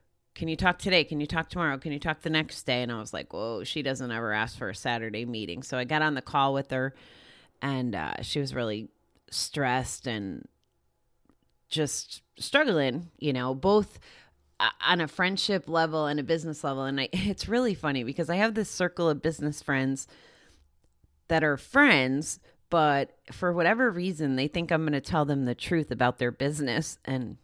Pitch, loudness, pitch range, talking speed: 150 Hz, -28 LUFS, 130-165 Hz, 190 wpm